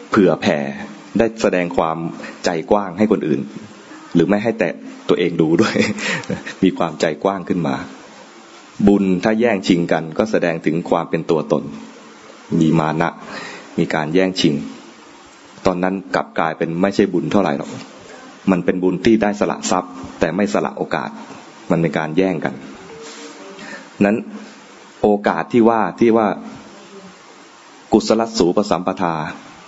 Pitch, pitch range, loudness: 95 Hz, 85-105 Hz, -18 LUFS